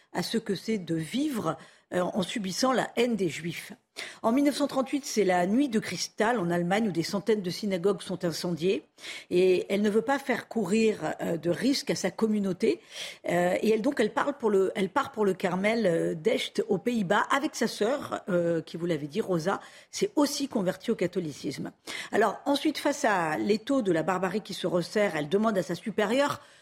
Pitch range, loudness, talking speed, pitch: 180-235 Hz, -28 LUFS, 190 wpm, 205 Hz